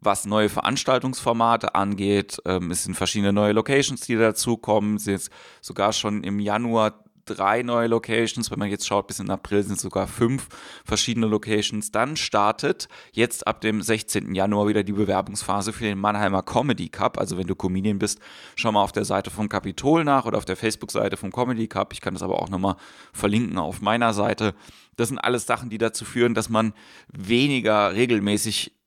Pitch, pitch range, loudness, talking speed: 105 Hz, 100-115 Hz, -23 LUFS, 190 wpm